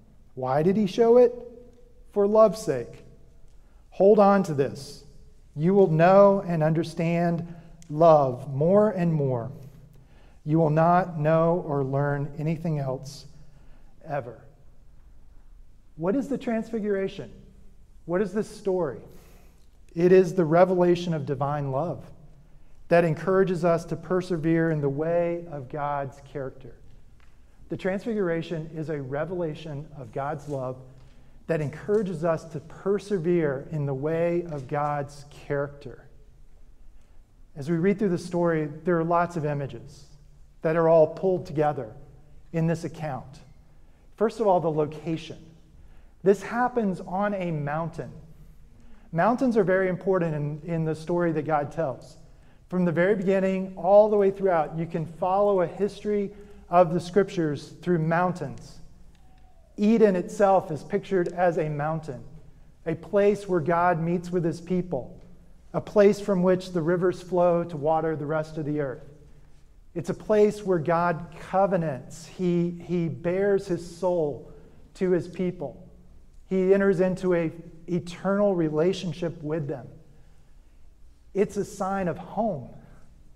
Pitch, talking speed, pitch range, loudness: 165 Hz, 135 wpm, 150-185 Hz, -25 LUFS